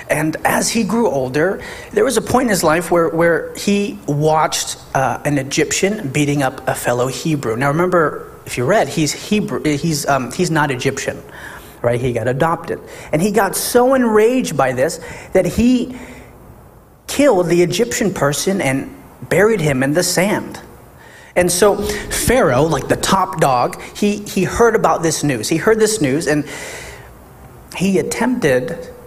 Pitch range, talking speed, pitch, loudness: 145-210 Hz, 165 wpm, 170 Hz, -16 LUFS